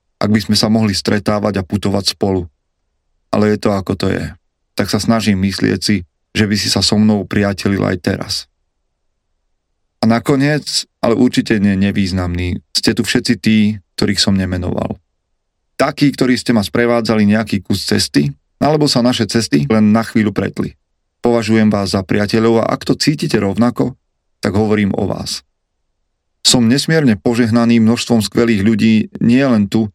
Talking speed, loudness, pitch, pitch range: 160 wpm, -14 LUFS, 105 Hz, 95-115 Hz